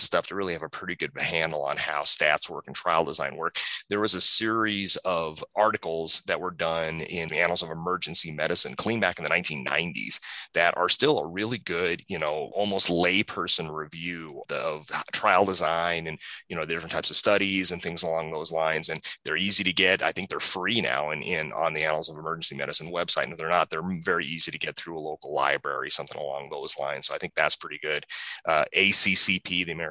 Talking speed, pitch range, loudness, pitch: 220 wpm, 80-95 Hz, -24 LUFS, 85 Hz